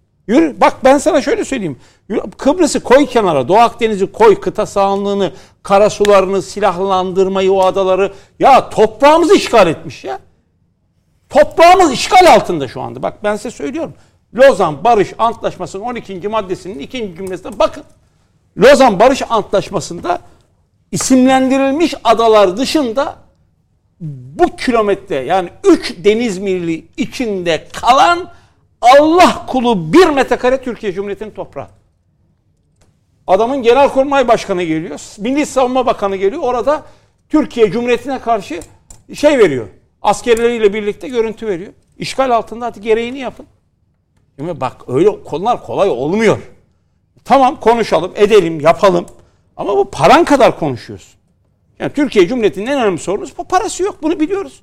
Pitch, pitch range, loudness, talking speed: 225 Hz, 190-275 Hz, -13 LUFS, 120 wpm